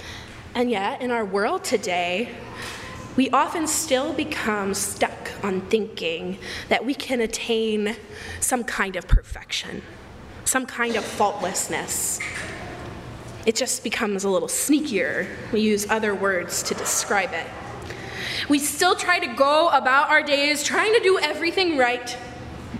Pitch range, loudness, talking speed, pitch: 215-295 Hz, -23 LUFS, 135 wpm, 245 Hz